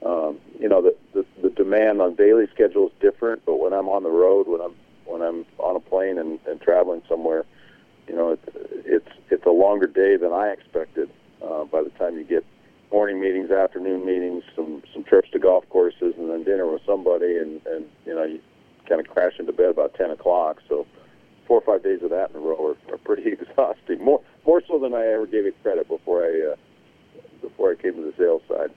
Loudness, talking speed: -22 LUFS, 225 wpm